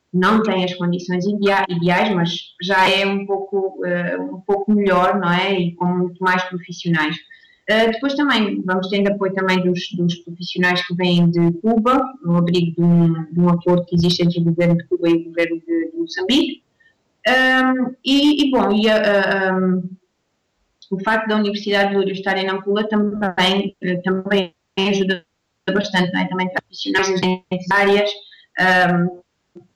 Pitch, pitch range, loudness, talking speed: 185 Hz, 175-205 Hz, -18 LUFS, 175 wpm